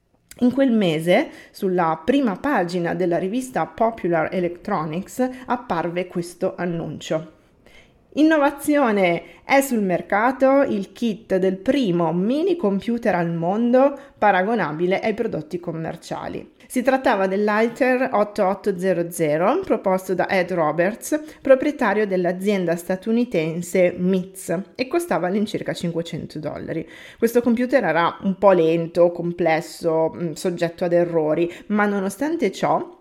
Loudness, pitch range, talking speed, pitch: -21 LUFS, 175-250 Hz, 105 wpm, 190 Hz